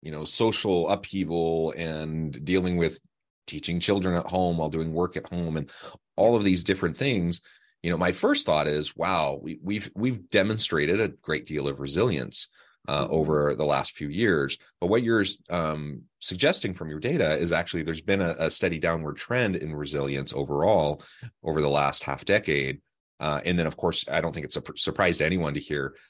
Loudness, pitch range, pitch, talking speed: -26 LUFS, 75-95 Hz, 85 Hz, 195 wpm